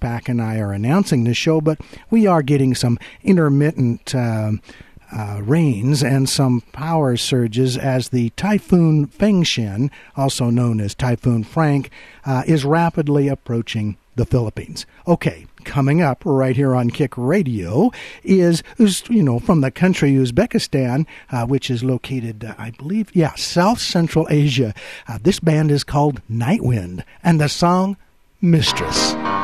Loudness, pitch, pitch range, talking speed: -18 LUFS, 135 Hz, 120-165 Hz, 145 wpm